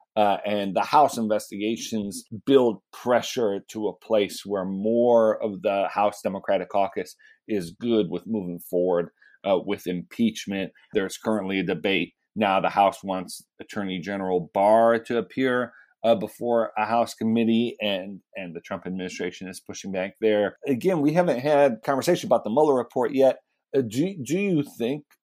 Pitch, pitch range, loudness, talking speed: 105 Hz, 95-115 Hz, -24 LUFS, 160 wpm